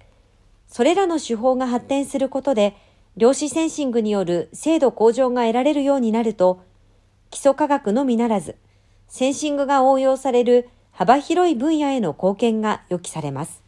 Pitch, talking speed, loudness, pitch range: 245 Hz, 330 characters per minute, -19 LUFS, 185-275 Hz